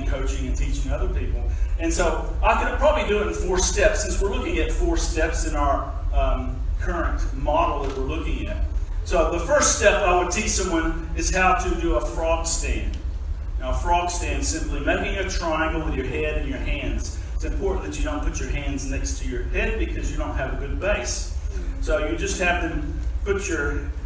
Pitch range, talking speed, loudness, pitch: 70-115 Hz, 210 wpm, -23 LUFS, 75 Hz